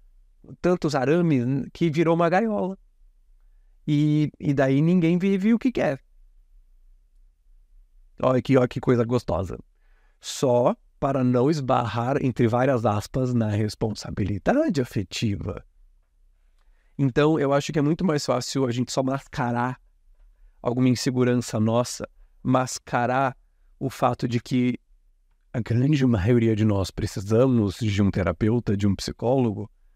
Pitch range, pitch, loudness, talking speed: 95-135 Hz, 120 Hz, -23 LUFS, 125 wpm